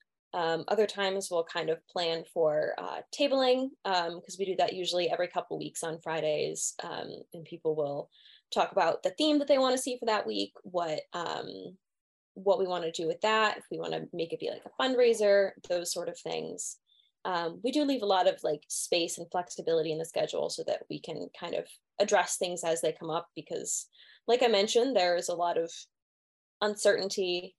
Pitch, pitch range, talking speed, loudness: 180 Hz, 165-220 Hz, 210 wpm, -31 LUFS